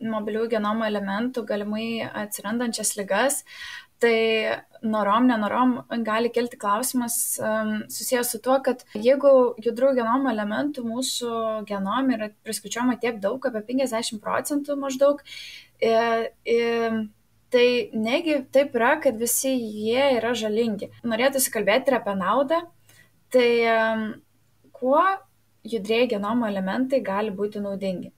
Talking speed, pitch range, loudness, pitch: 110 wpm, 220-260 Hz, -24 LUFS, 235 Hz